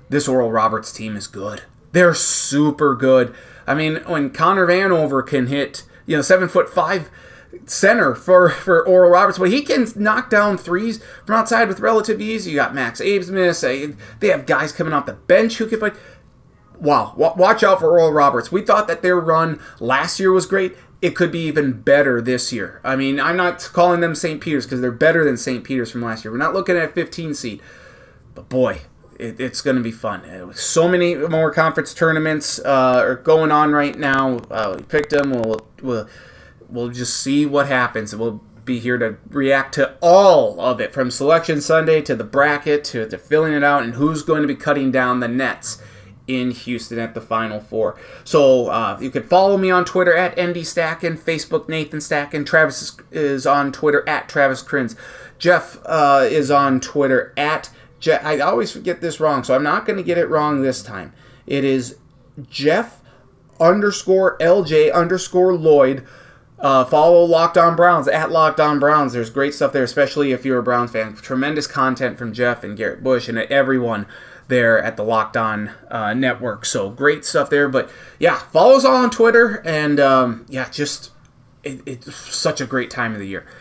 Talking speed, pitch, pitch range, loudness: 195 wpm, 145 Hz, 130-170 Hz, -17 LUFS